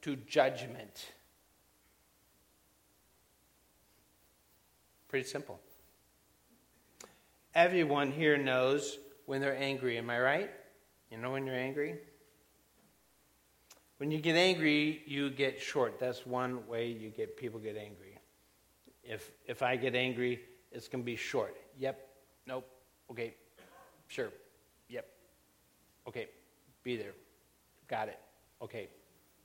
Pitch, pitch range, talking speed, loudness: 125 Hz, 105-140 Hz, 110 wpm, -35 LUFS